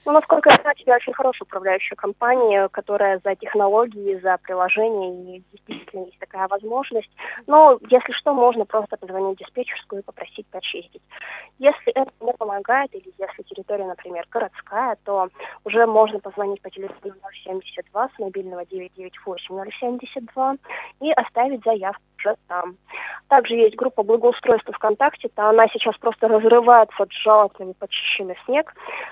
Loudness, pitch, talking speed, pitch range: -19 LUFS, 215 Hz, 140 wpm, 195-245 Hz